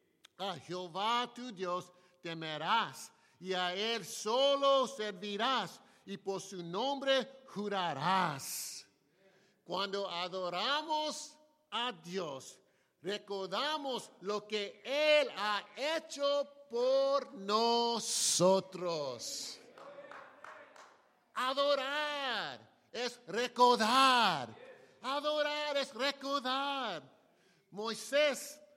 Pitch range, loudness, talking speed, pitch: 190-280 Hz, -34 LUFS, 70 wpm, 235 Hz